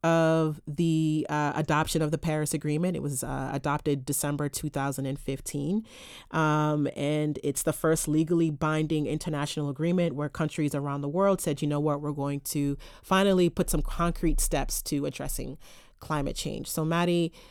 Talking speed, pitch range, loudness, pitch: 160 wpm, 145-165 Hz, -28 LUFS, 155 Hz